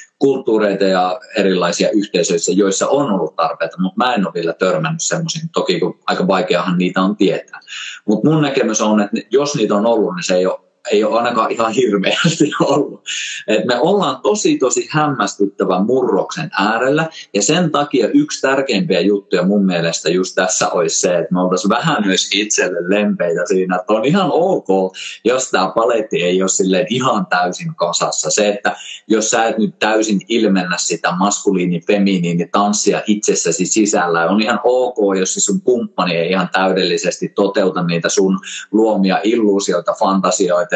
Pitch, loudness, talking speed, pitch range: 100 Hz, -15 LUFS, 160 wpm, 95-135 Hz